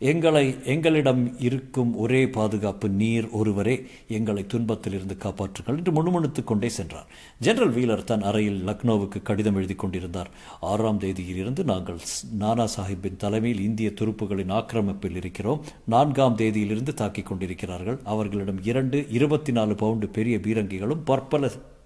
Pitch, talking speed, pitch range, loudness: 110 Hz, 120 wpm, 100-125 Hz, -25 LUFS